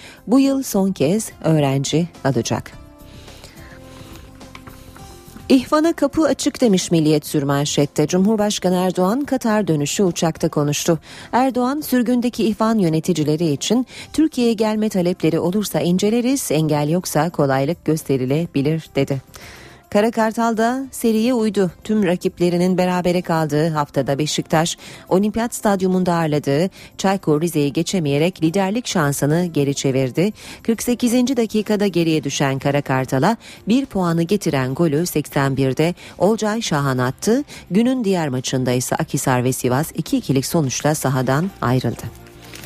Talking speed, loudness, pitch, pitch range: 110 wpm, -19 LUFS, 170 Hz, 145-215 Hz